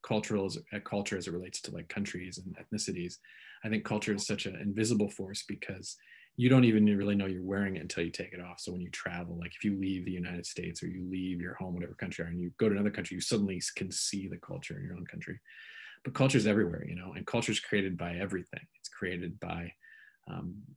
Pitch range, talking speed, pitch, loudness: 90-105 Hz, 250 wpm, 95 Hz, -34 LUFS